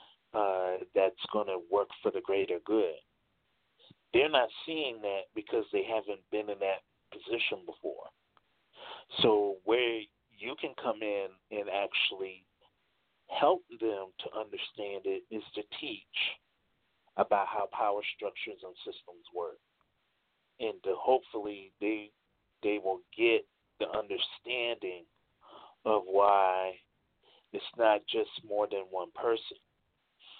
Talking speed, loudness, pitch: 120 wpm, -33 LUFS, 115 Hz